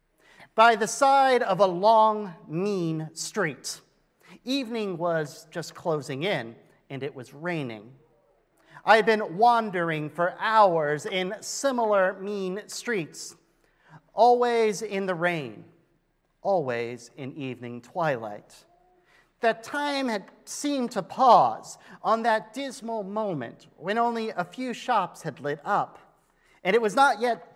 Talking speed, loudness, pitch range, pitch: 125 wpm, -25 LUFS, 160-225 Hz, 195 Hz